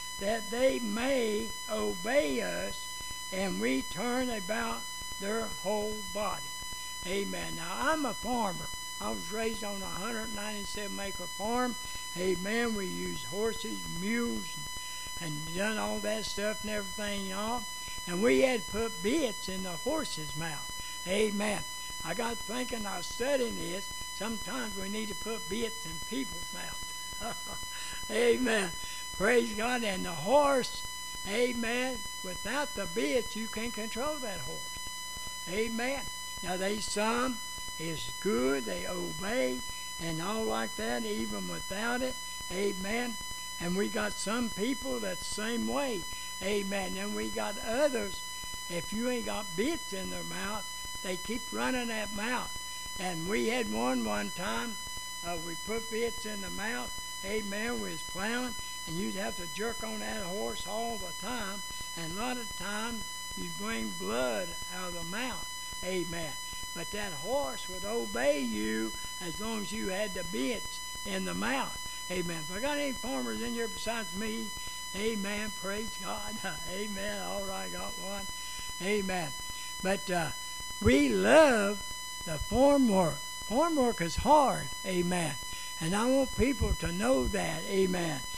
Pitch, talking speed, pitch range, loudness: 215 Hz, 150 wpm, 195-255 Hz, -33 LUFS